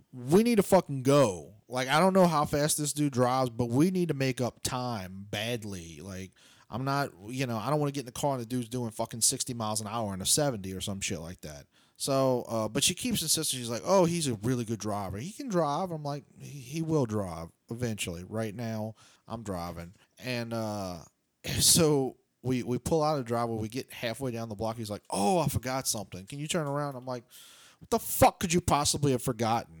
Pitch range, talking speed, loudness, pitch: 110-145 Hz, 235 wpm, -29 LUFS, 125 Hz